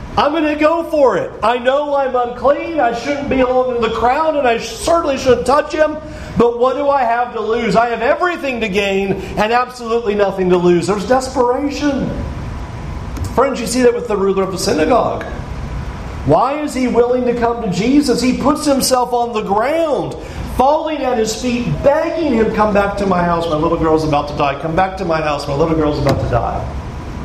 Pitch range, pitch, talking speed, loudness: 200-275 Hz, 240 Hz, 205 wpm, -15 LUFS